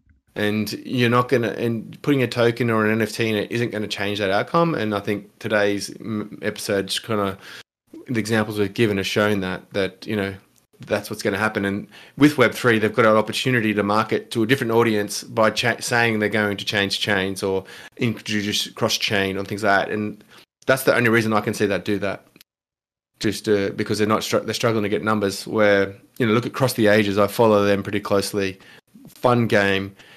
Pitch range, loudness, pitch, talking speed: 100-115 Hz, -21 LUFS, 105 Hz, 210 wpm